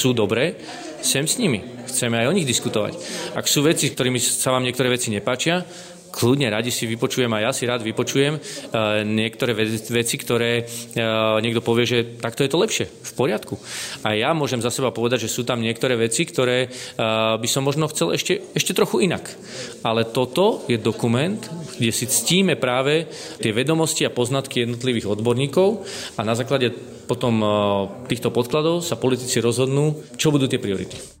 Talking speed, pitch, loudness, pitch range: 165 wpm, 125 Hz, -21 LUFS, 115-140 Hz